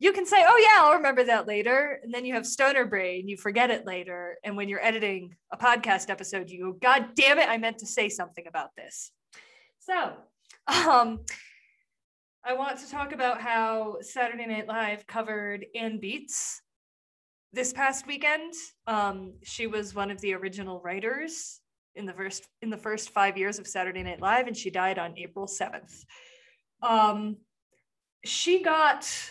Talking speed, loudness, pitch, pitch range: 170 wpm, -26 LUFS, 225 Hz, 200-270 Hz